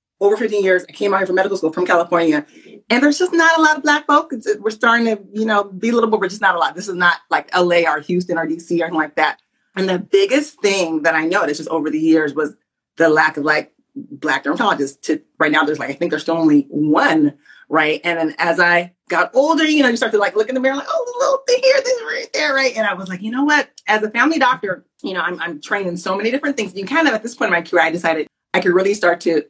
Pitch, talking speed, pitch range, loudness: 195 Hz, 285 wpm, 170-265 Hz, -17 LUFS